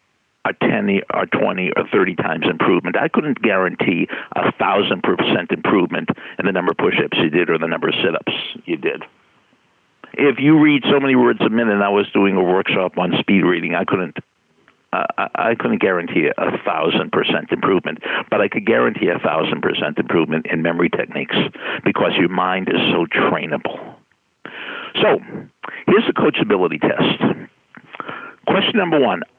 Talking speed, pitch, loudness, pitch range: 170 wpm, 110 Hz, -17 LUFS, 95-140 Hz